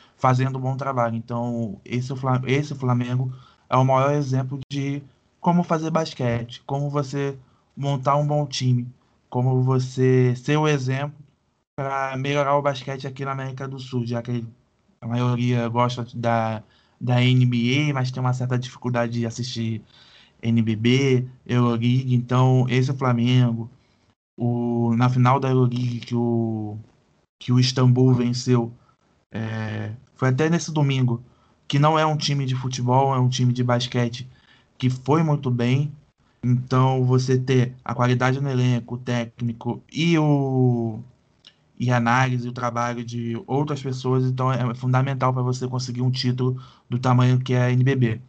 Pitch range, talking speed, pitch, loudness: 120-135 Hz, 150 wpm, 125 Hz, -22 LUFS